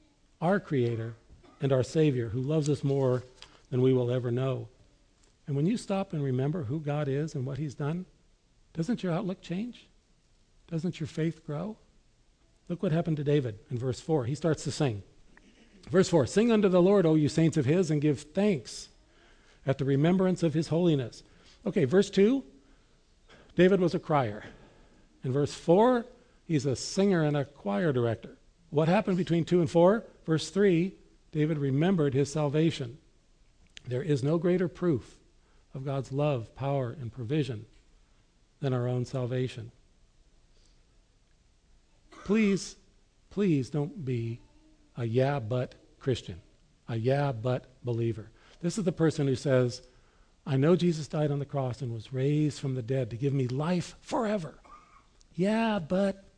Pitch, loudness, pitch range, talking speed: 150 Hz, -29 LUFS, 130-175 Hz, 160 wpm